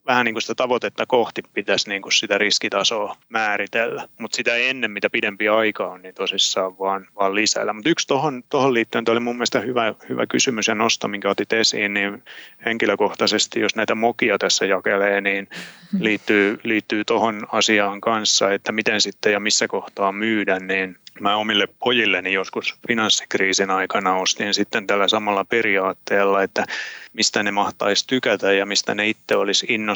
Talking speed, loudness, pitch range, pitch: 160 wpm, -20 LUFS, 100-115 Hz, 105 Hz